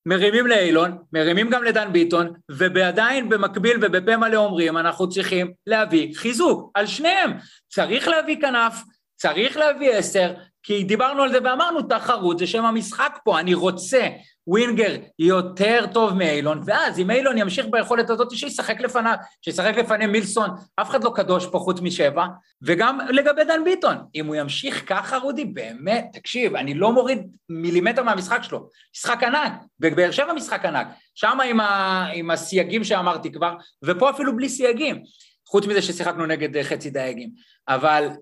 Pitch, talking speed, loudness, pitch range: 205 Hz, 150 wpm, -21 LUFS, 175-240 Hz